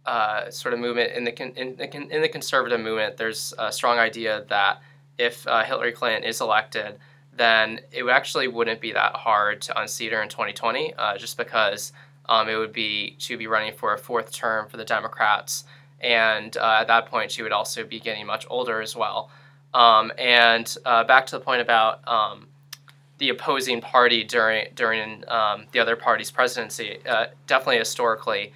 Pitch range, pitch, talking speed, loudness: 110-140 Hz, 120 Hz, 185 wpm, -22 LUFS